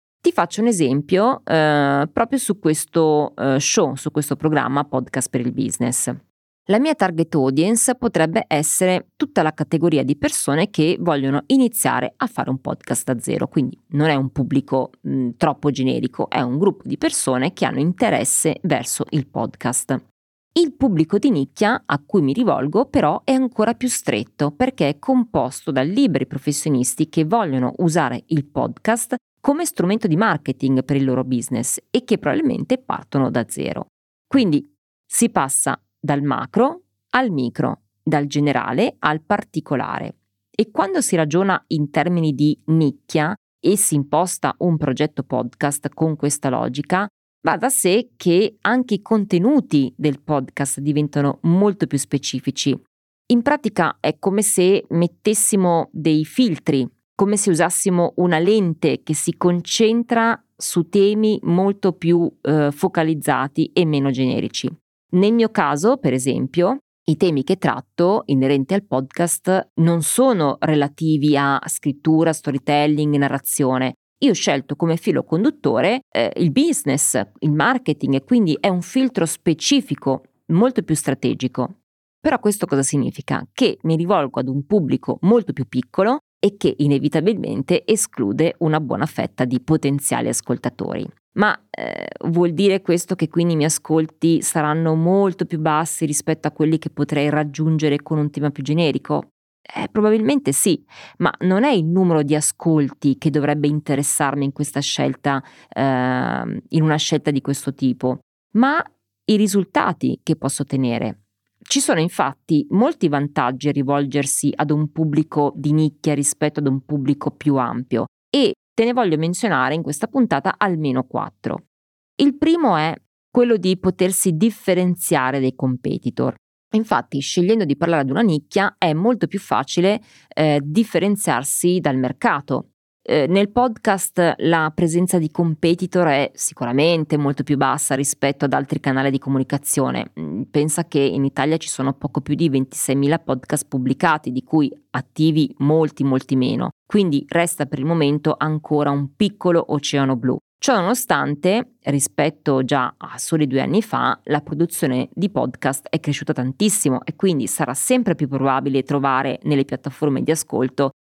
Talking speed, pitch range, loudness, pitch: 150 wpm, 140-190 Hz, -19 LUFS, 155 Hz